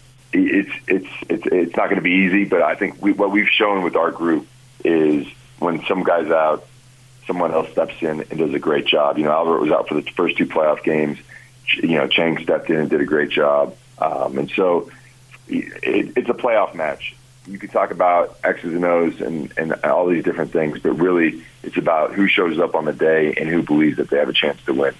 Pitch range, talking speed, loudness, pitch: 80-130 Hz, 230 wpm, -19 LUFS, 100 Hz